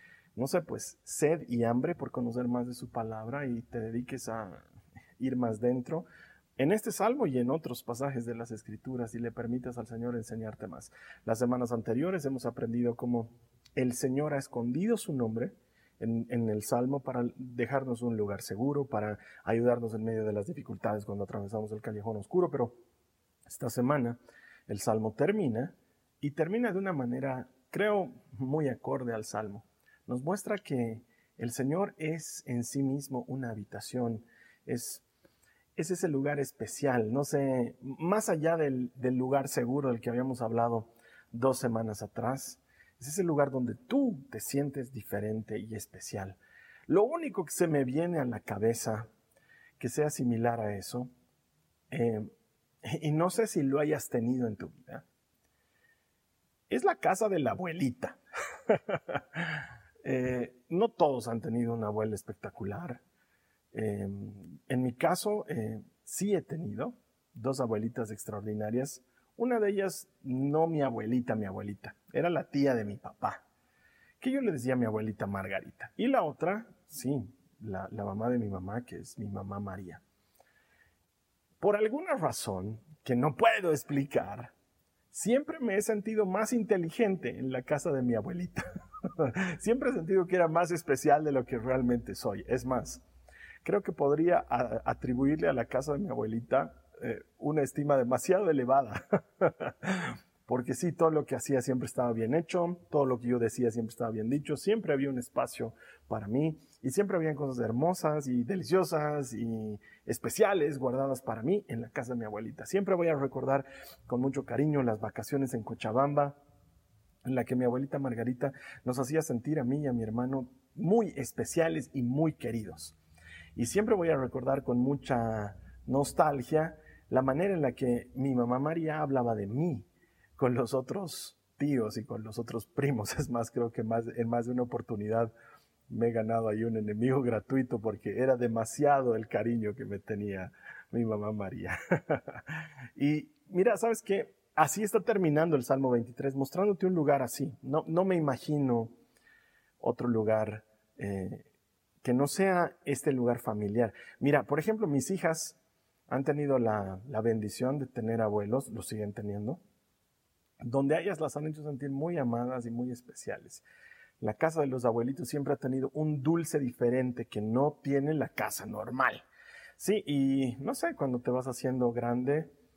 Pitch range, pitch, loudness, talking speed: 115-150 Hz, 125 Hz, -32 LUFS, 165 wpm